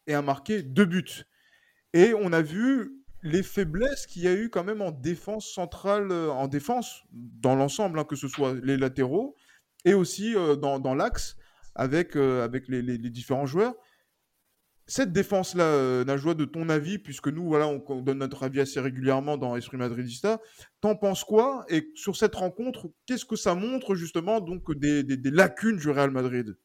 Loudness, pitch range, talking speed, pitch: -27 LUFS, 135-205 Hz, 190 wpm, 165 Hz